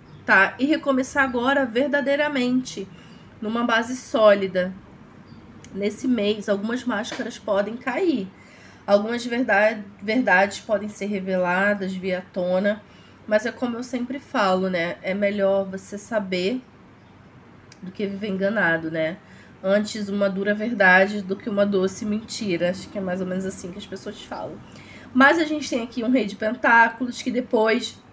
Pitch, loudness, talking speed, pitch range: 210 Hz, -22 LUFS, 145 wpm, 195-240 Hz